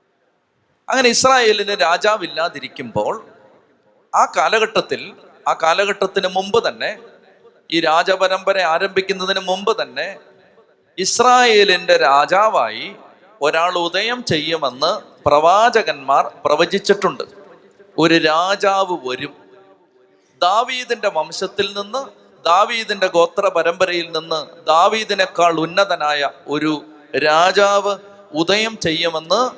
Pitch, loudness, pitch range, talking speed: 190 Hz, -16 LUFS, 165-205 Hz, 75 wpm